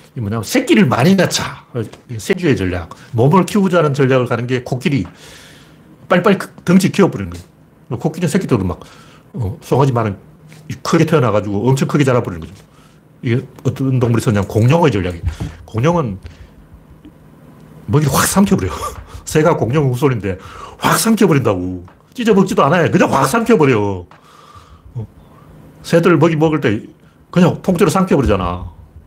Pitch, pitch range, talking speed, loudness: 130 Hz, 100-165 Hz, 330 characters per minute, -15 LUFS